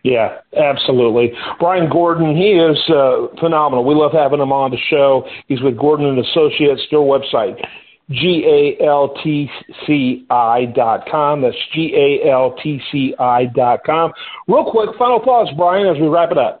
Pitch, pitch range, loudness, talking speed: 150 Hz, 135-170 Hz, -14 LUFS, 125 wpm